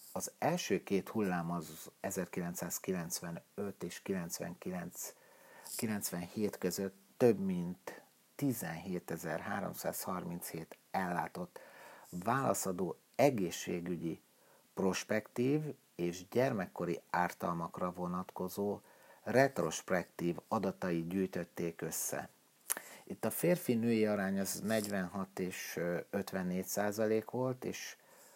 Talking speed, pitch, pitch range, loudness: 75 wpm, 95 Hz, 90-110 Hz, -37 LUFS